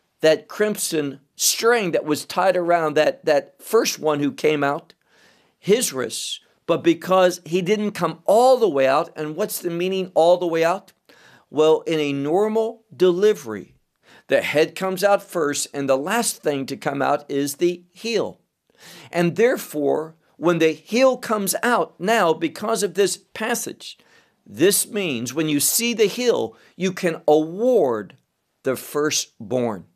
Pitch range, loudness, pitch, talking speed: 150-210 Hz, -21 LUFS, 175 Hz, 155 wpm